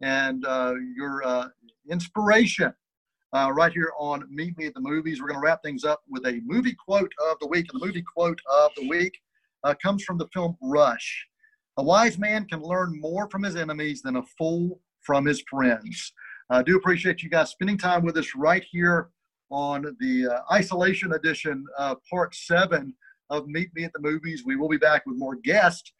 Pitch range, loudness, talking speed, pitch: 145-185 Hz, -25 LUFS, 200 wpm, 160 Hz